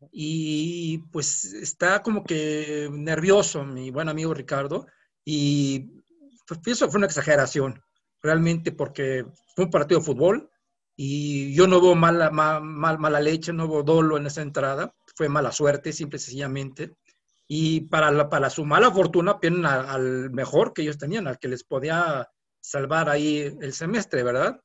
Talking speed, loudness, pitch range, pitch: 160 wpm, -23 LUFS, 145-170 Hz, 155 Hz